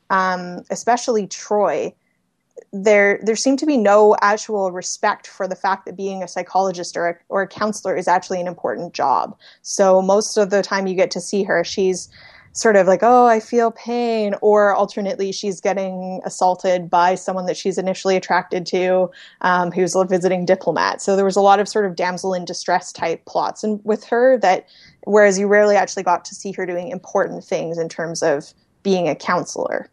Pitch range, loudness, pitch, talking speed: 185-205 Hz, -18 LUFS, 195 Hz, 195 wpm